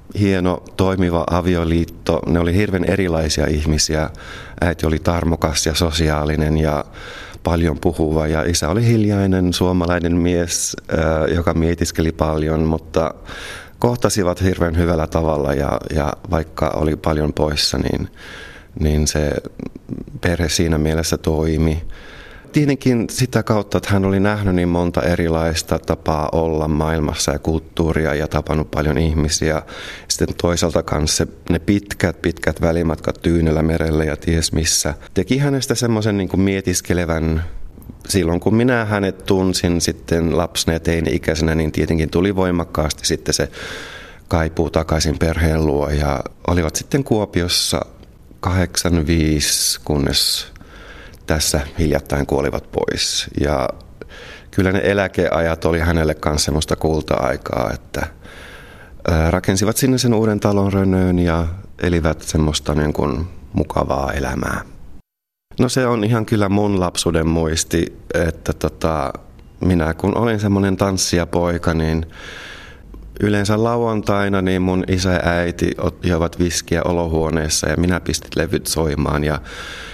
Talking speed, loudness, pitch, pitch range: 125 wpm, -18 LUFS, 85 Hz, 80-95 Hz